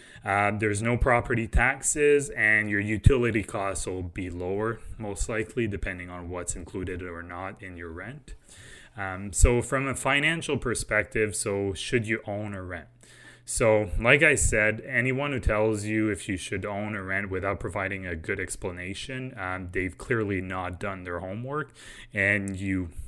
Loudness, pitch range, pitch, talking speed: -27 LUFS, 95-115 Hz, 100 Hz, 165 wpm